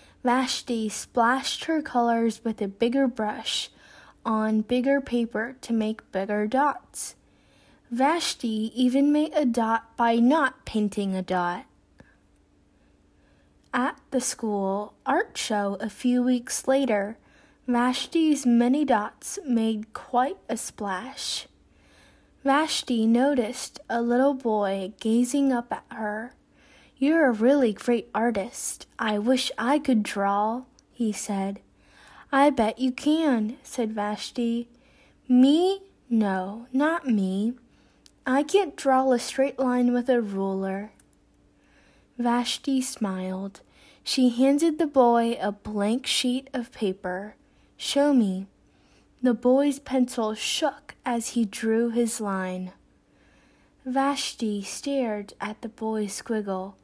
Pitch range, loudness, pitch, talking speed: 210-265 Hz, -25 LUFS, 235 Hz, 115 wpm